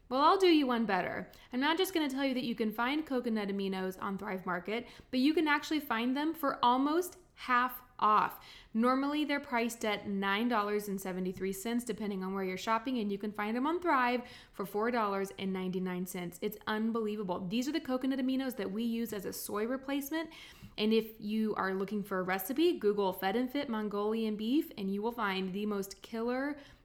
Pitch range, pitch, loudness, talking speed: 200-265 Hz, 225 Hz, -33 LUFS, 190 wpm